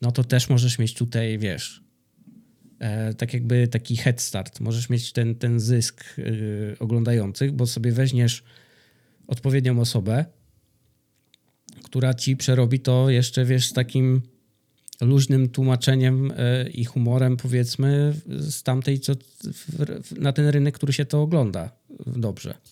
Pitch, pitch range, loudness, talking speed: 125 Hz, 120-135 Hz, -23 LUFS, 120 wpm